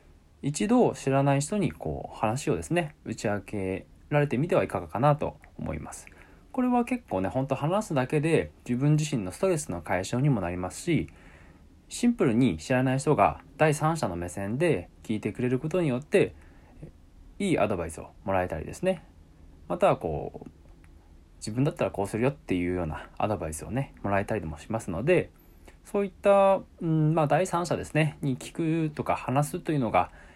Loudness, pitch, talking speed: -28 LUFS, 125 Hz, 320 characters per minute